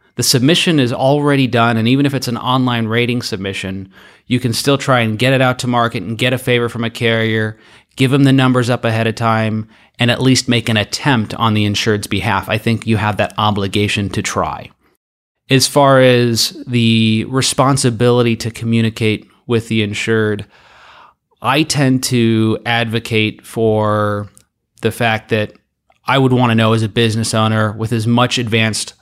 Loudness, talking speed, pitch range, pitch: -14 LUFS, 180 wpm, 110-125 Hz, 115 Hz